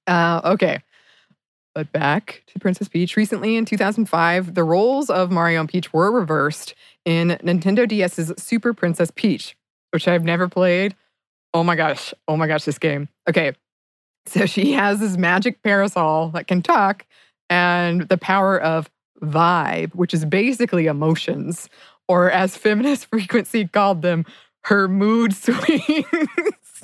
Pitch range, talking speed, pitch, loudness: 170-210 Hz, 145 wpm, 180 Hz, -19 LUFS